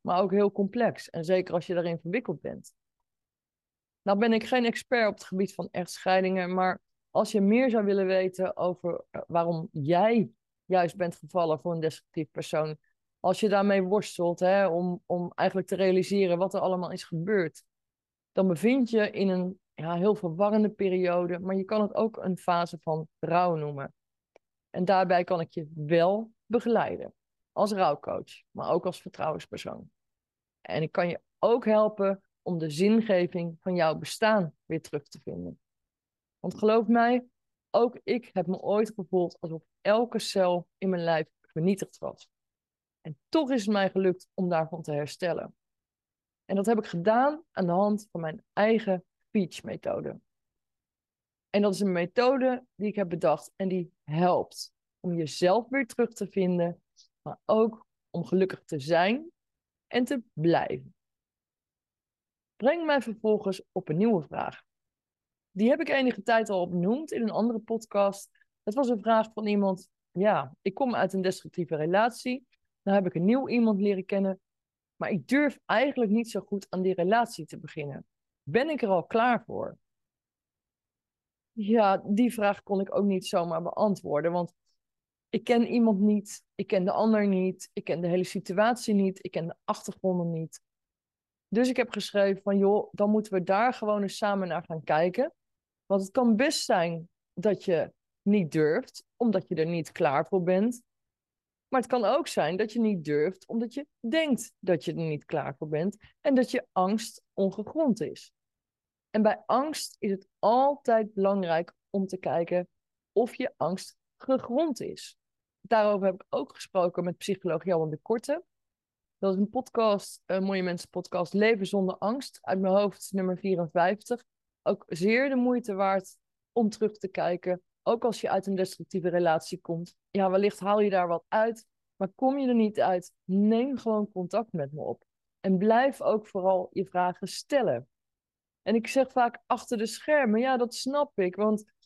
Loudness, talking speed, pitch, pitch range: -28 LUFS, 175 wpm, 195 Hz, 180-225 Hz